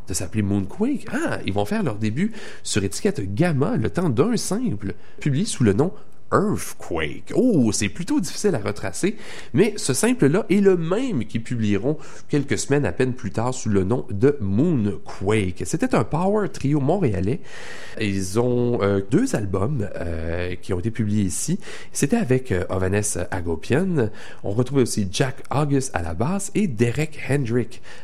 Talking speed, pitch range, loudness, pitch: 170 wpm, 100-150 Hz, -23 LUFS, 120 Hz